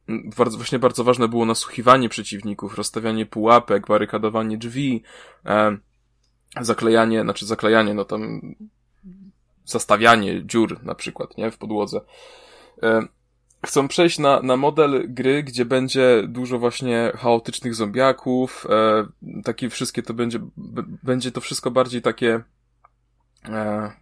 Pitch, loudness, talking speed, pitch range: 120 Hz, -20 LUFS, 120 wpm, 110-130 Hz